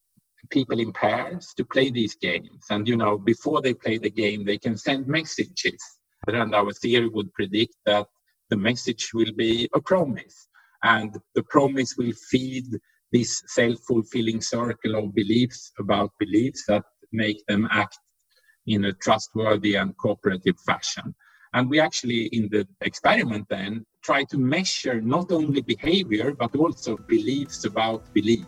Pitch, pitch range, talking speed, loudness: 115 Hz, 110-130 Hz, 150 wpm, -24 LUFS